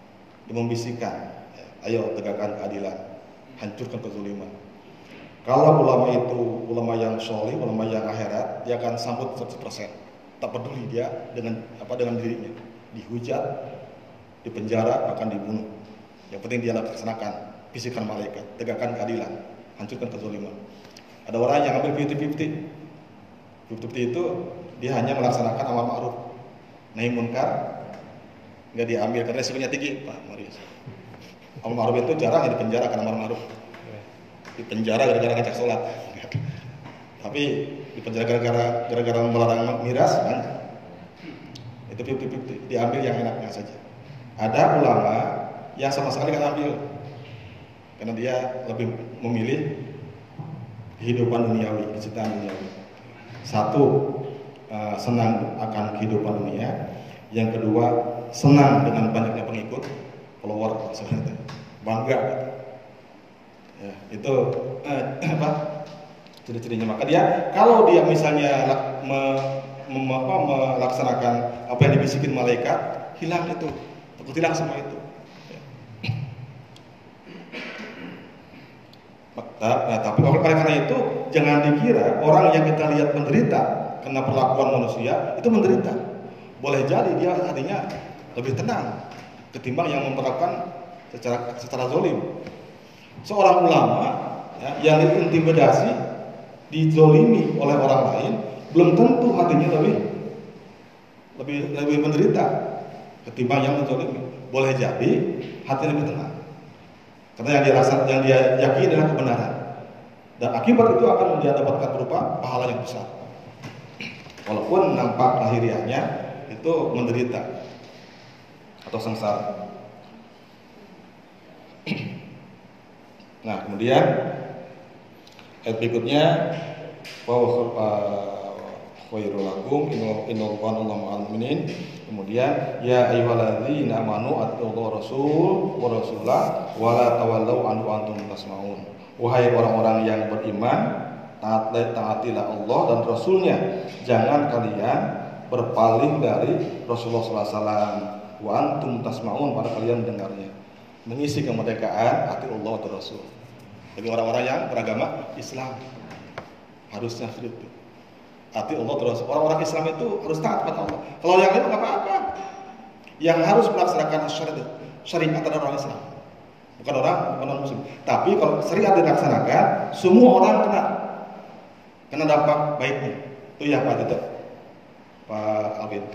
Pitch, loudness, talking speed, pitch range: 125 Hz, -22 LUFS, 110 wpm, 115-145 Hz